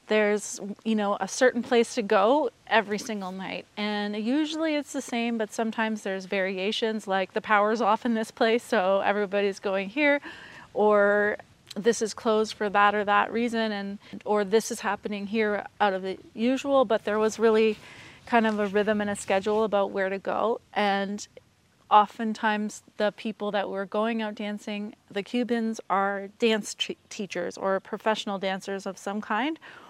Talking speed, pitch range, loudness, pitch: 175 wpm, 200-225 Hz, -26 LUFS, 210 Hz